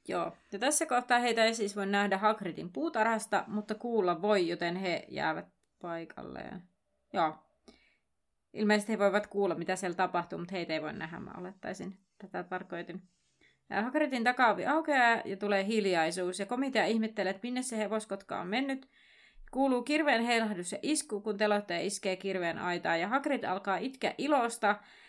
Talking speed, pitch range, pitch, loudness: 155 wpm, 185-240 Hz, 205 Hz, -32 LUFS